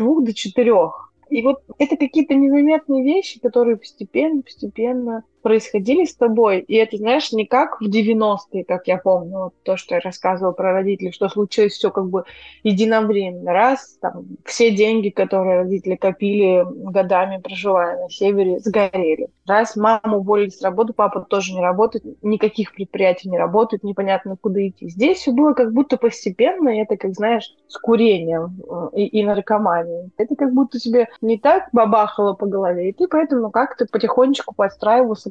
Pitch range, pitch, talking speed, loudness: 195-240 Hz, 215 Hz, 165 wpm, -18 LUFS